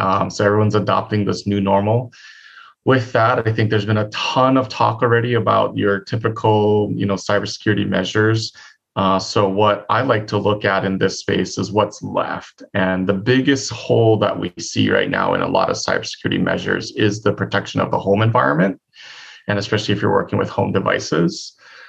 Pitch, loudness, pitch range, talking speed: 105 Hz, -18 LUFS, 100-115 Hz, 190 wpm